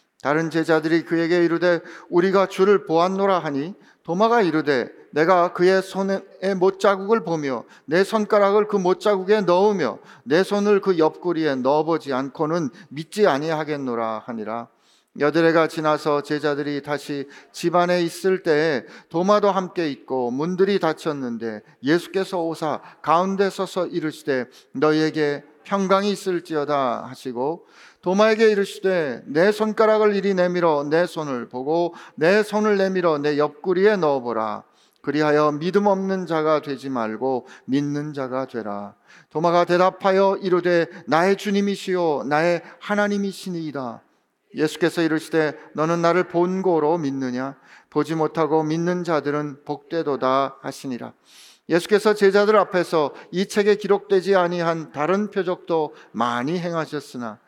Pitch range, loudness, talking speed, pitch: 150-190 Hz, -21 LUFS, 310 characters per minute, 165 Hz